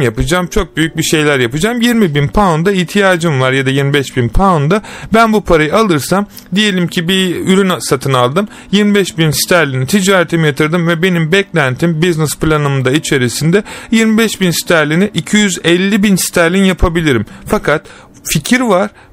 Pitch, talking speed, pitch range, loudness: 175 Hz, 145 wpm, 155-200 Hz, -11 LUFS